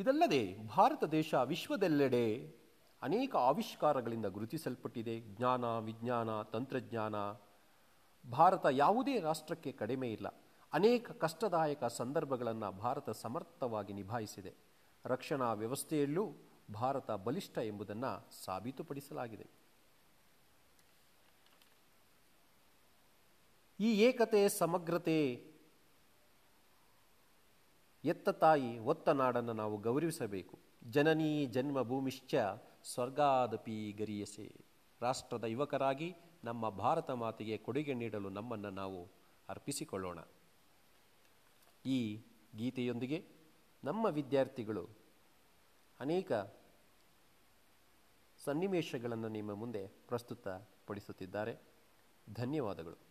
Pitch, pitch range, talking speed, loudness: 125 Hz, 110-155 Hz, 70 wpm, -37 LUFS